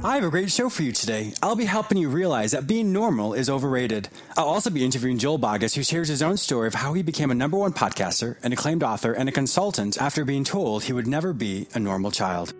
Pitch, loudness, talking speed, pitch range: 140 Hz, -24 LUFS, 250 wpm, 115-180 Hz